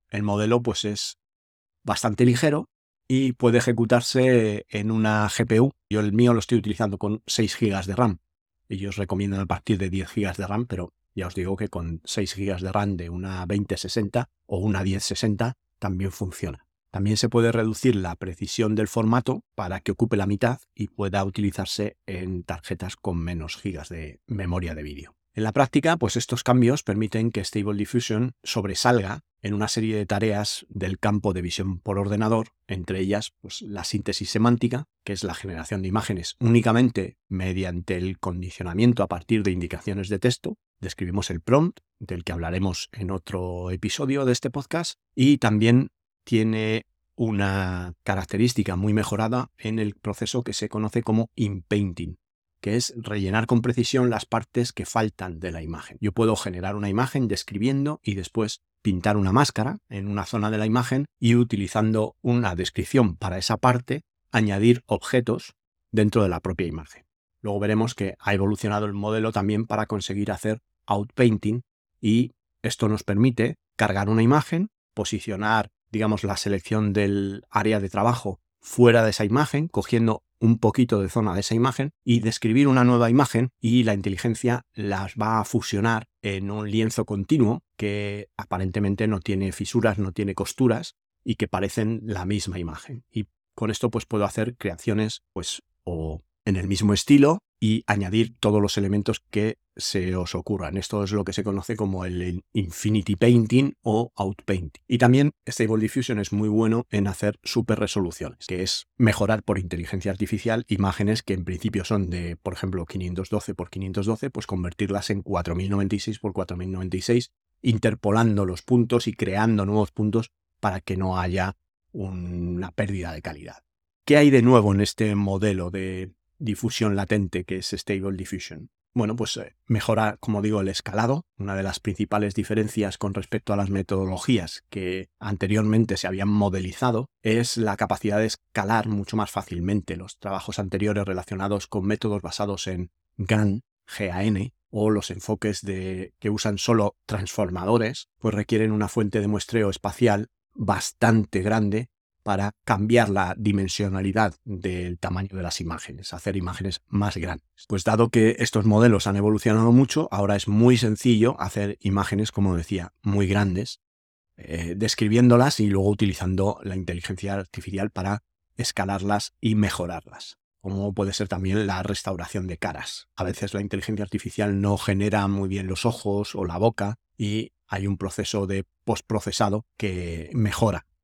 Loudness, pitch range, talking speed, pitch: -24 LUFS, 95-115 Hz, 160 wpm, 105 Hz